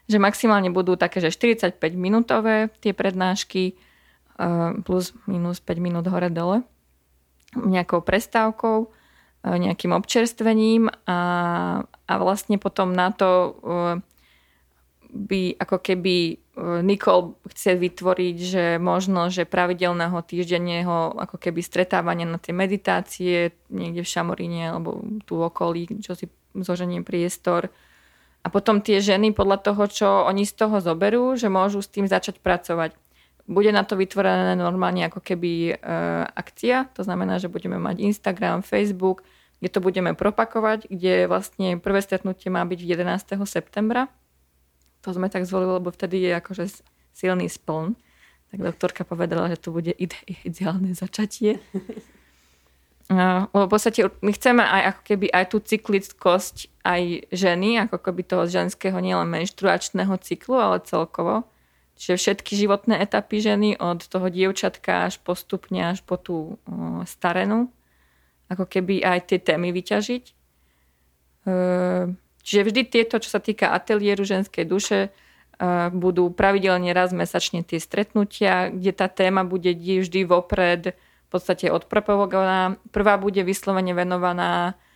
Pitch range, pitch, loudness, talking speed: 175-200 Hz, 185 Hz, -23 LUFS, 135 wpm